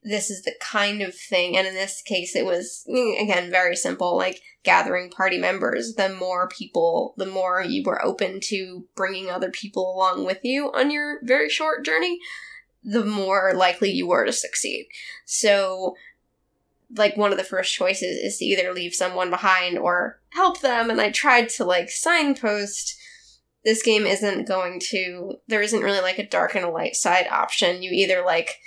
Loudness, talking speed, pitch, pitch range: -22 LUFS, 180 wpm, 195 Hz, 185-225 Hz